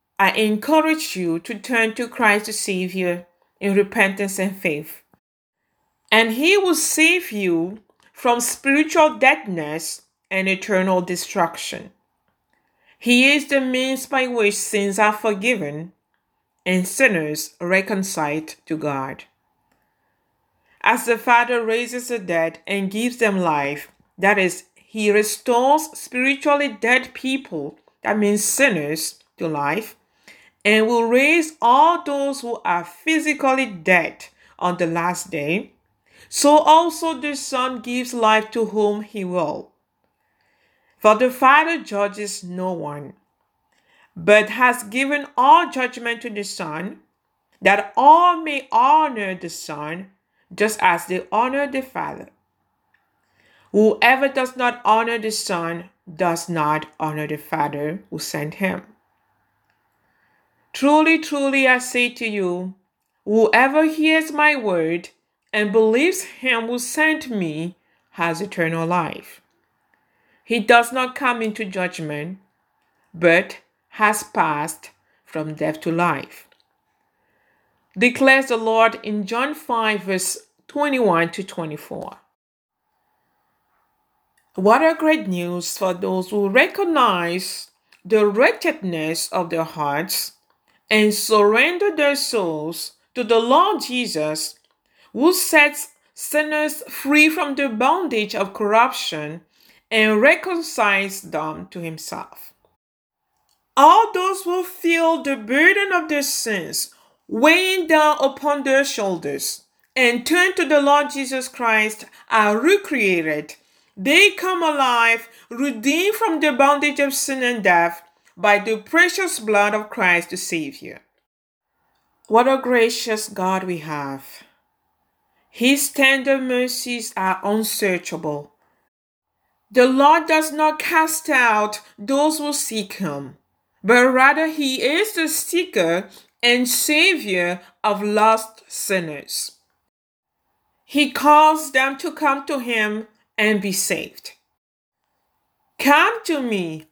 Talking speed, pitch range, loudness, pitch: 115 wpm, 185-285 Hz, -18 LUFS, 230 Hz